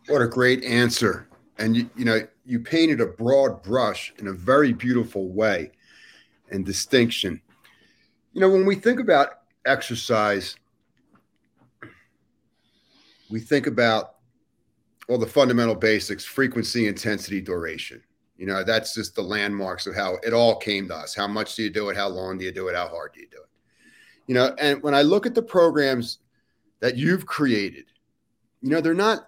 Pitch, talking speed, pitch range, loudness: 115 Hz, 170 wpm, 105-135 Hz, -23 LUFS